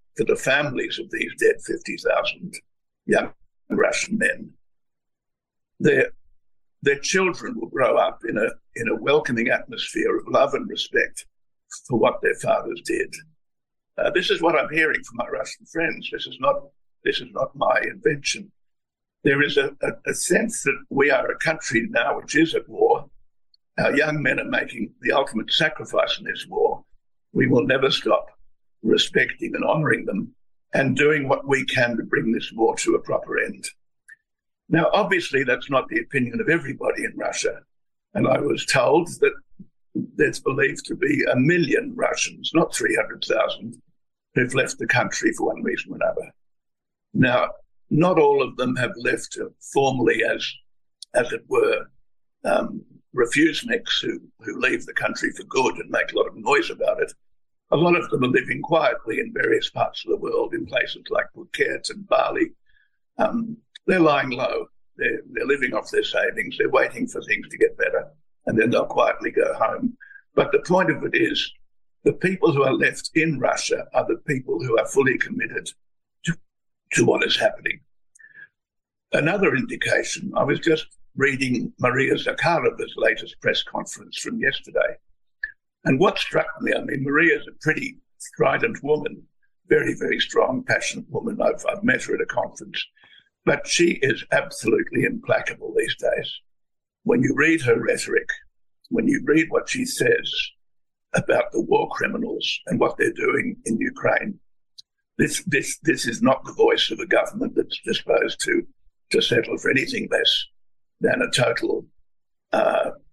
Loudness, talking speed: -22 LUFS, 165 wpm